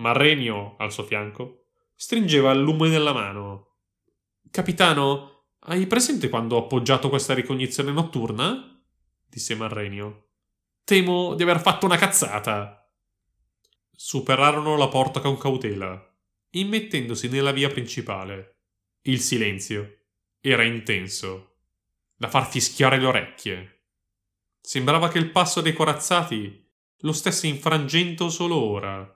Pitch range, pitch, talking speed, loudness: 100-155 Hz, 130 Hz, 115 wpm, -22 LUFS